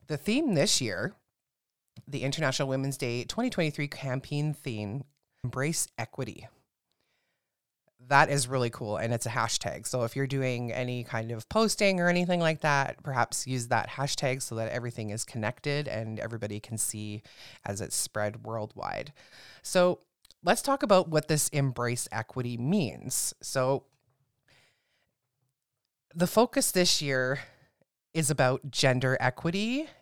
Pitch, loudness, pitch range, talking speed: 130 Hz, -29 LUFS, 120-150 Hz, 135 wpm